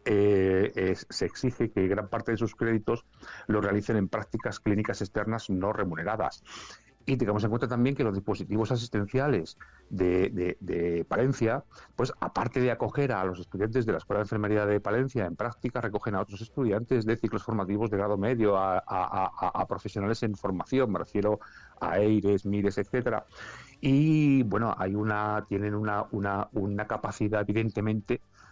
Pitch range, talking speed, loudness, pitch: 100-115 Hz, 170 wpm, -29 LUFS, 105 Hz